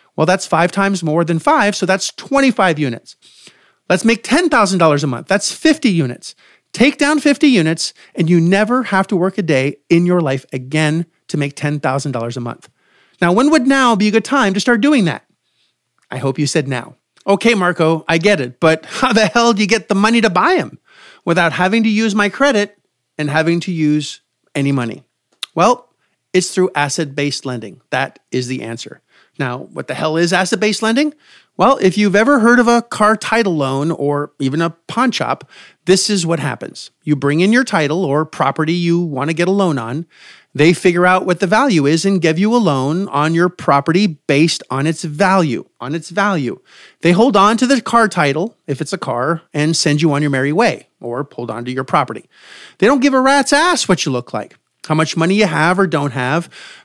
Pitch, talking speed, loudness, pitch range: 170 Hz, 210 wpm, -15 LUFS, 150-210 Hz